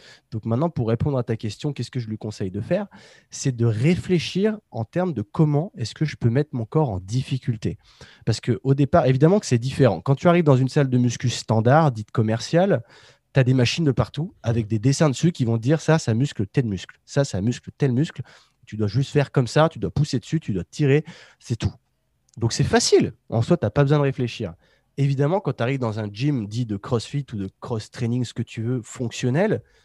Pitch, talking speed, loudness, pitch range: 130 Hz, 230 wpm, -22 LUFS, 115-150 Hz